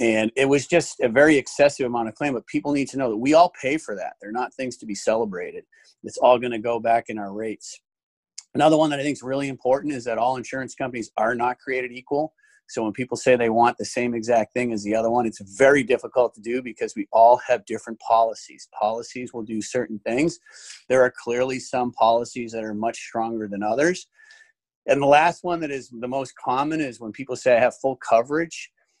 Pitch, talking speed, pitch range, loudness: 125 Hz, 230 wpm, 115-140 Hz, -22 LUFS